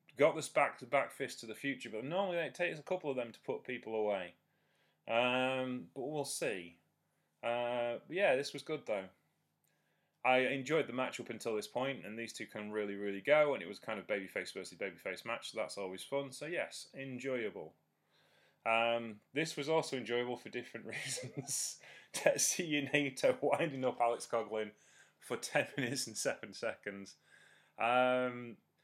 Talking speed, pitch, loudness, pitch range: 175 wpm, 125 Hz, -37 LUFS, 110-140 Hz